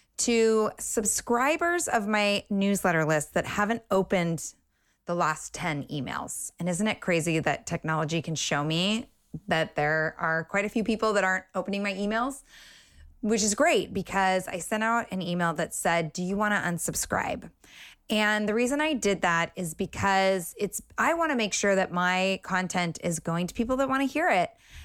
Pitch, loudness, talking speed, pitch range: 190 Hz, -27 LUFS, 185 wpm, 170-220 Hz